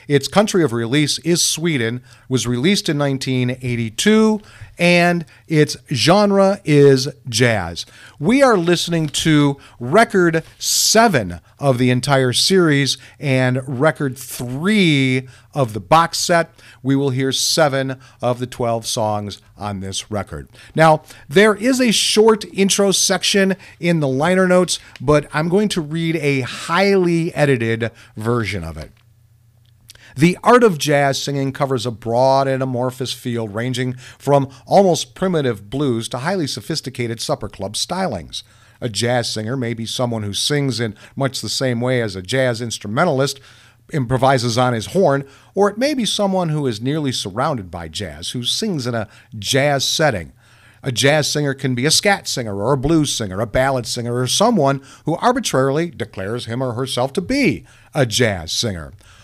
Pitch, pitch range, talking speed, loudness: 135 Hz, 115-160 Hz, 155 wpm, -17 LUFS